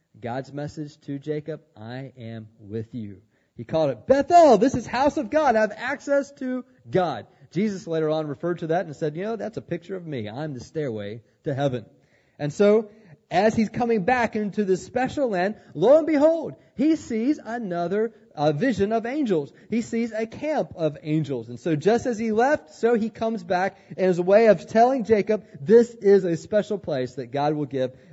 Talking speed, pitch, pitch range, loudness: 200 wpm, 185 Hz, 145-230 Hz, -23 LUFS